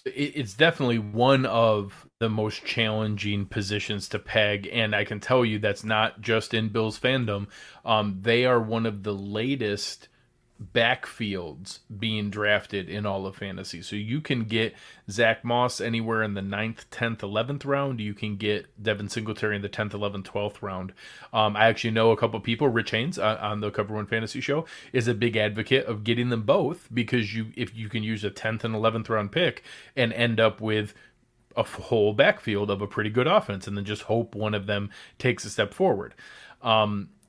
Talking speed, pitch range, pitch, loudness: 195 wpm, 105-115 Hz, 110 Hz, -26 LUFS